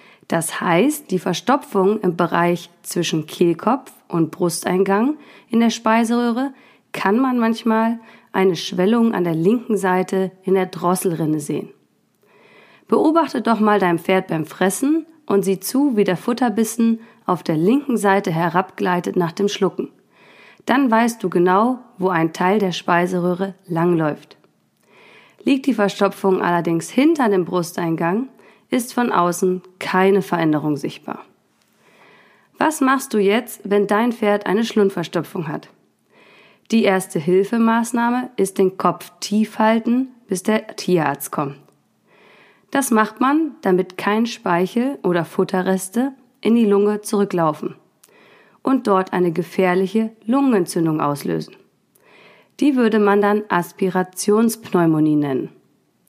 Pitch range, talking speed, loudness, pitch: 180-230 Hz, 125 wpm, -19 LUFS, 195 Hz